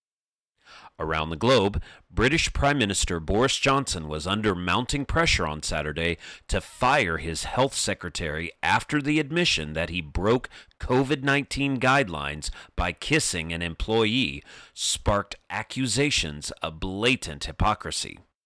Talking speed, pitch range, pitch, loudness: 120 wpm, 80-135 Hz, 95 Hz, -25 LUFS